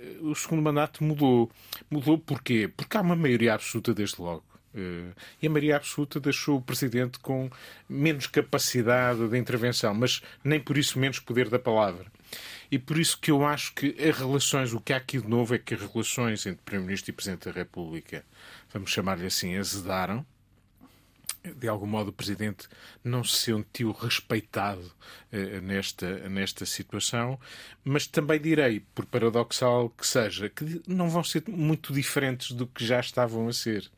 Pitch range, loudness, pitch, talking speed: 105-145 Hz, -28 LUFS, 120 Hz, 165 wpm